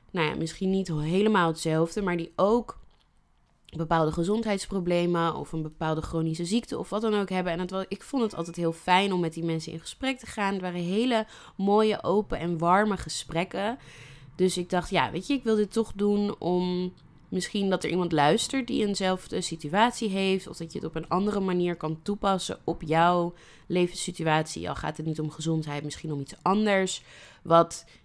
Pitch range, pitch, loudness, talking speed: 165-200 Hz, 180 Hz, -27 LUFS, 195 wpm